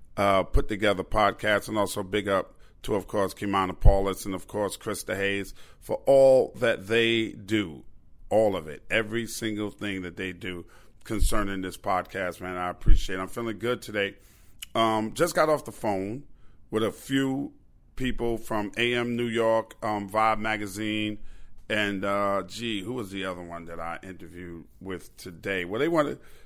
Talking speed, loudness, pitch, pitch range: 170 wpm, -27 LUFS, 105 Hz, 95-115 Hz